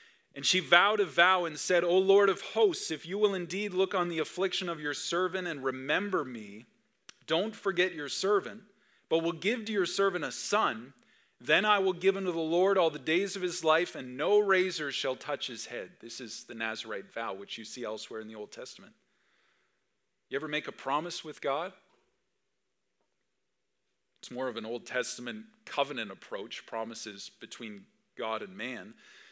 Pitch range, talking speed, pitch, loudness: 125-190 Hz, 185 wpm, 170 Hz, -30 LUFS